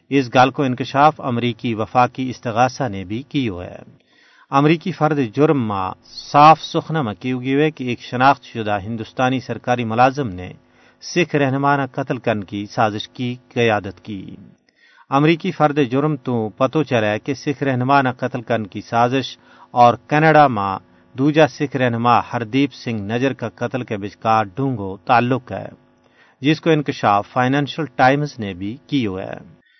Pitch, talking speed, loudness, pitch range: 125 Hz, 145 wpm, -18 LUFS, 115-140 Hz